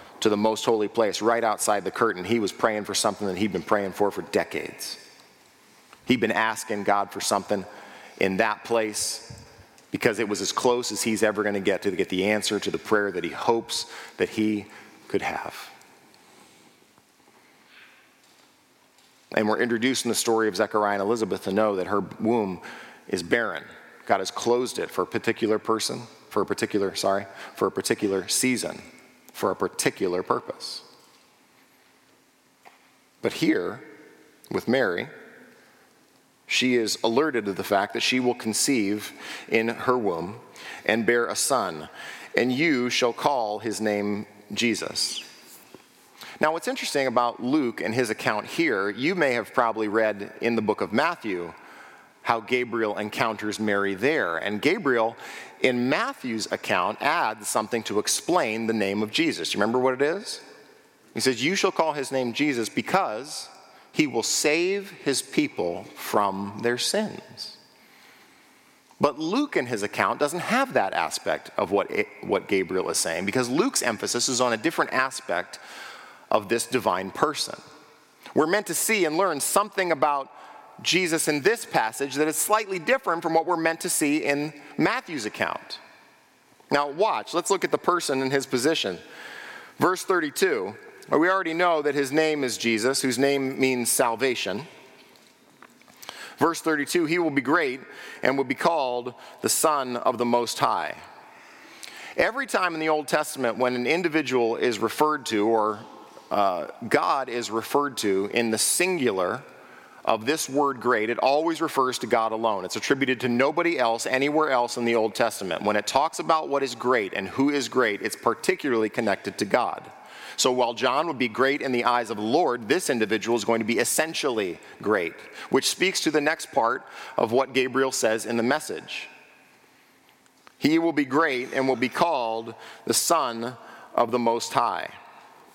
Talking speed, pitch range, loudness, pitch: 165 wpm, 110-150 Hz, -25 LUFS, 125 Hz